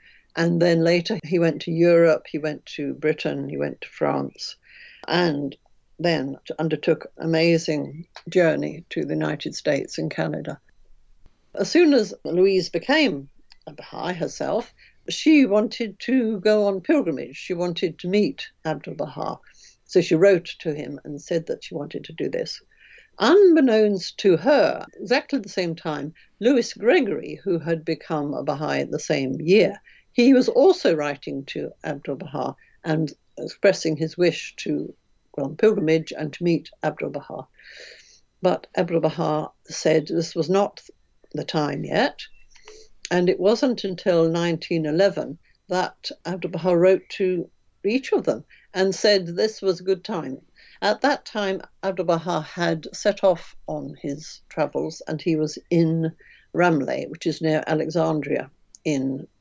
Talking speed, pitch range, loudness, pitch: 150 wpm, 155-200 Hz, -23 LUFS, 170 Hz